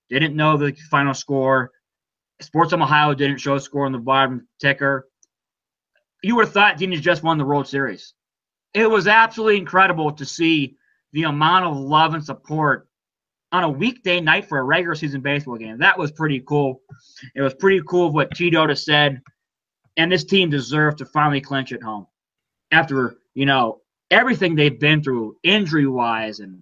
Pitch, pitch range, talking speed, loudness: 150 Hz, 135-170 Hz, 180 wpm, -18 LUFS